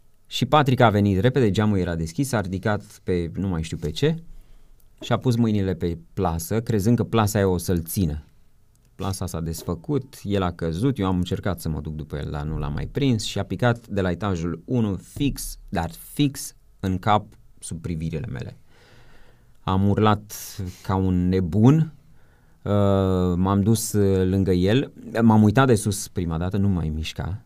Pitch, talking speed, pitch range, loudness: 100 Hz, 180 wpm, 90-115 Hz, -23 LUFS